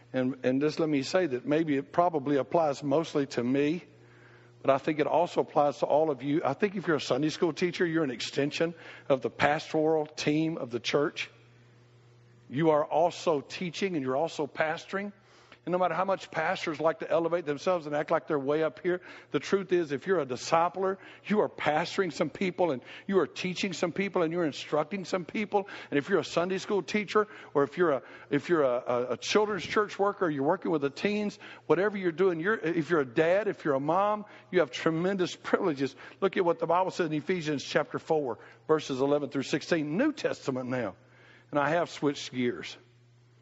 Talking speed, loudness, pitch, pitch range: 210 wpm, -29 LUFS, 160 Hz, 140-180 Hz